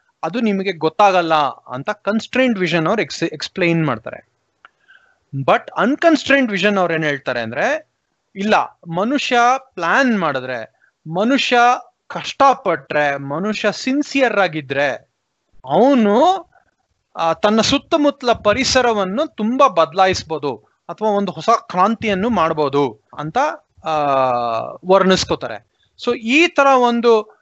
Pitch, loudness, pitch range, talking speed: 210 Hz, -17 LUFS, 165-255 Hz, 90 wpm